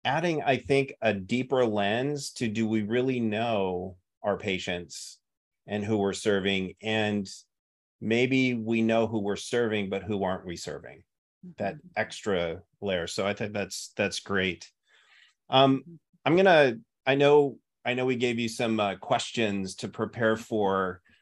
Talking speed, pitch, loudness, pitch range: 155 wpm, 110 Hz, -27 LUFS, 100-125 Hz